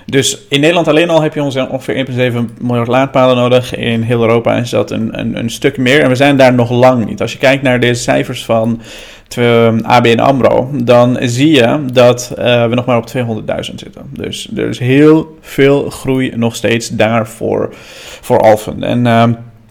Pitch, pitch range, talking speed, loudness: 125 Hz, 115-135 Hz, 200 wpm, -11 LUFS